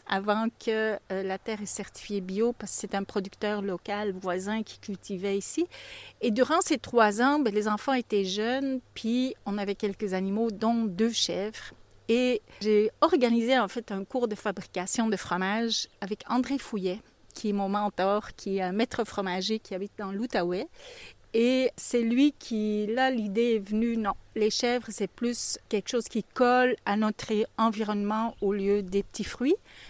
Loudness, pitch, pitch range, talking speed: -28 LUFS, 215 Hz, 200-235 Hz, 175 wpm